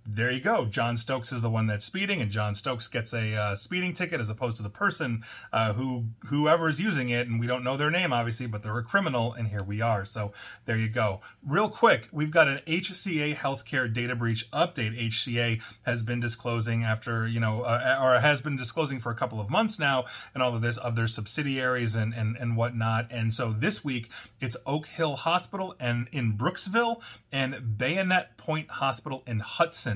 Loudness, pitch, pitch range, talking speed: -28 LUFS, 120 Hz, 115-145 Hz, 210 wpm